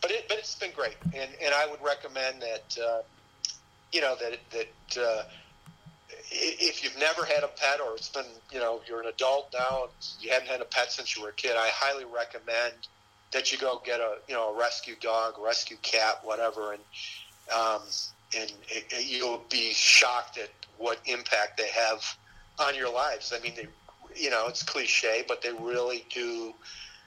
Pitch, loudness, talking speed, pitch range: 120 Hz, -29 LUFS, 190 wpm, 110-135 Hz